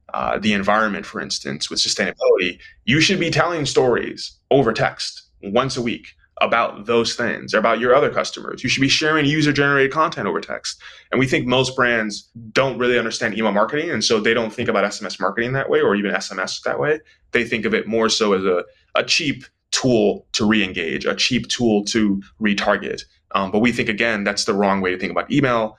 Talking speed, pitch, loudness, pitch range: 210 wpm, 115 Hz, -19 LUFS, 105-135 Hz